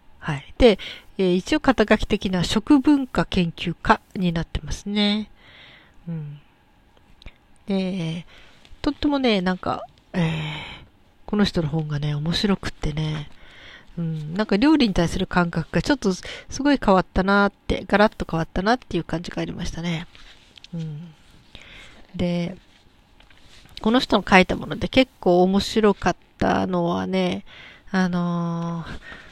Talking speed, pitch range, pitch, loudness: 260 characters per minute, 170-210 Hz, 185 Hz, -22 LUFS